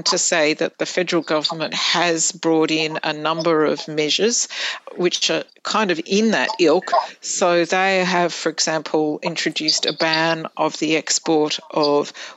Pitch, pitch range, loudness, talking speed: 165 Hz, 155-180 Hz, -19 LUFS, 155 wpm